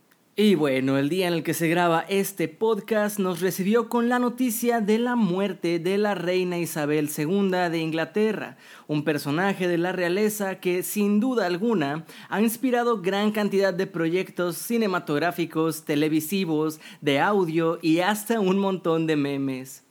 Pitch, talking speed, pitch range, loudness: 185 Hz, 155 wpm, 160-210 Hz, -24 LUFS